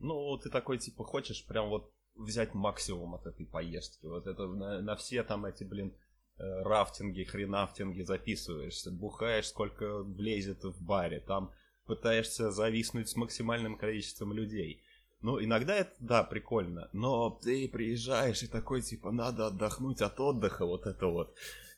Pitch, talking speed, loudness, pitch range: 110 Hz, 145 wpm, -36 LUFS, 100-120 Hz